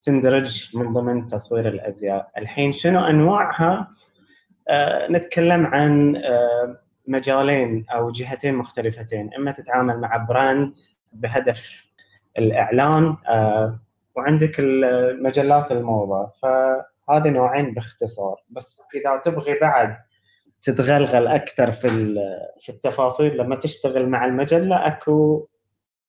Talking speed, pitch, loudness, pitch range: 95 wpm, 130 Hz, -20 LUFS, 115-145 Hz